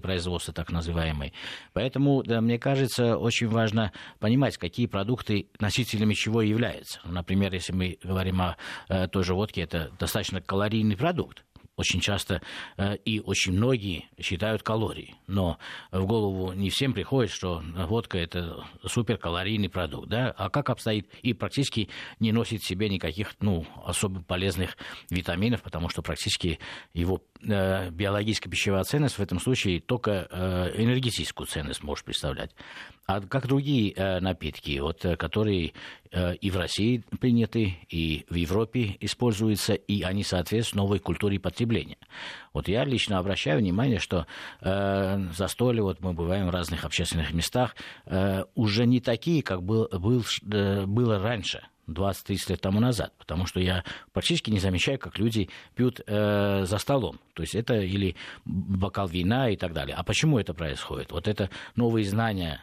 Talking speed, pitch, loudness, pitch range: 150 wpm, 100 Hz, -28 LUFS, 90-110 Hz